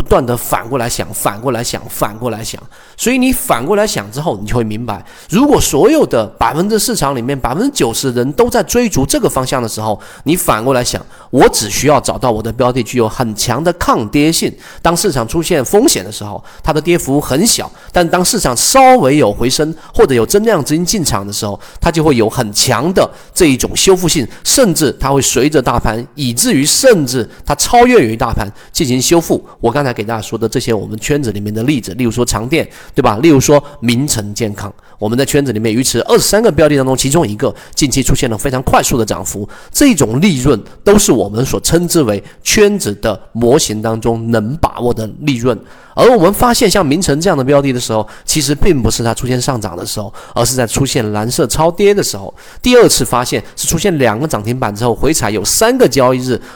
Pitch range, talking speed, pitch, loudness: 115-160 Hz, 330 characters per minute, 130 Hz, -12 LUFS